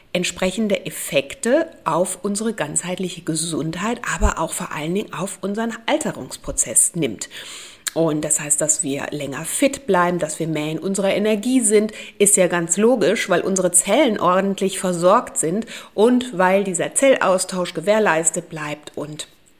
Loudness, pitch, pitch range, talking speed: -19 LUFS, 185 Hz, 160-210 Hz, 145 wpm